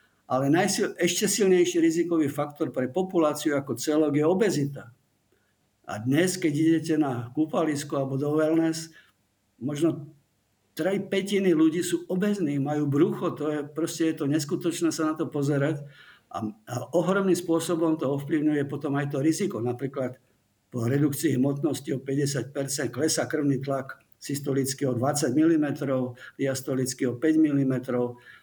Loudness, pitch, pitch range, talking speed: -26 LUFS, 150 Hz, 135-165 Hz, 140 wpm